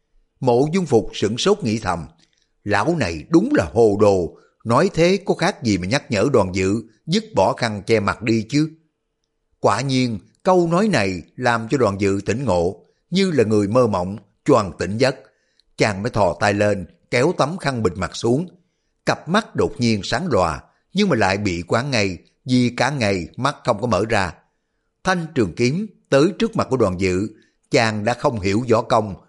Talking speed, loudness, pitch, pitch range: 195 wpm, -20 LUFS, 120 Hz, 100-155 Hz